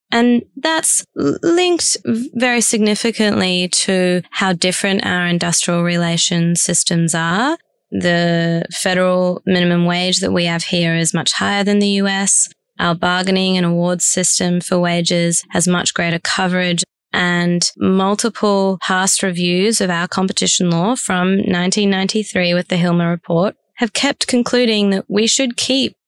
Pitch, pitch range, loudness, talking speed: 185 Hz, 175-205 Hz, -15 LUFS, 135 wpm